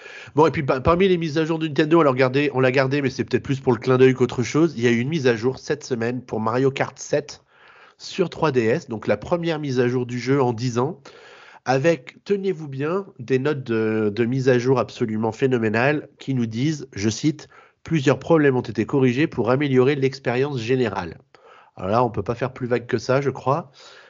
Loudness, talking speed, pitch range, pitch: -21 LUFS, 225 wpm, 125-145 Hz, 130 Hz